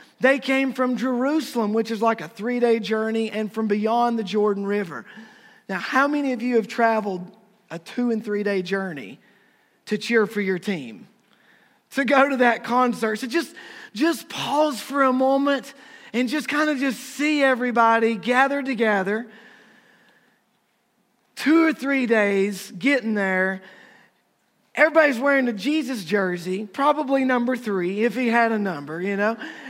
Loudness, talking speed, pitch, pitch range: -22 LUFS, 155 wpm, 235 Hz, 210-270 Hz